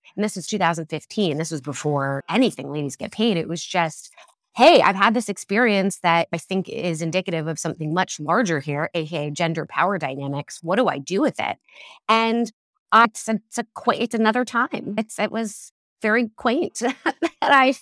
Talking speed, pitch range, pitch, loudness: 180 wpm, 160-225 Hz, 195 Hz, -22 LUFS